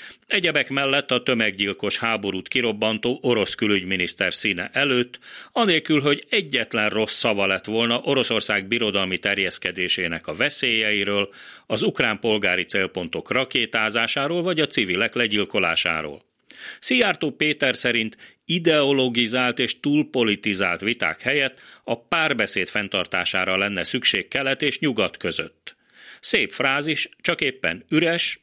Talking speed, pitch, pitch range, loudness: 110 wpm, 115 Hz, 100-135 Hz, -21 LUFS